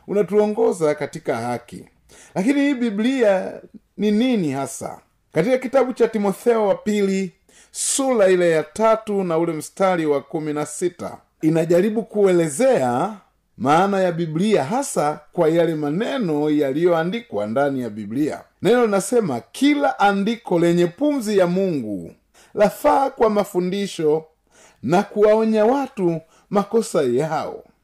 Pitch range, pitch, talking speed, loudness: 160-225 Hz, 195 Hz, 110 wpm, -20 LUFS